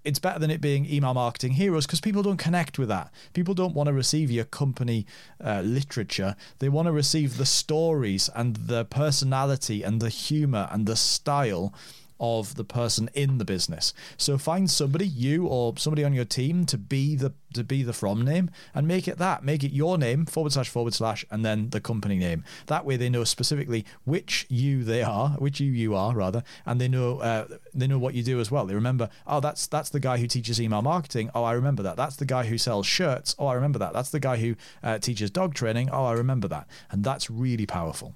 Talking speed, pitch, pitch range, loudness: 225 wpm, 130 Hz, 115-150 Hz, -26 LUFS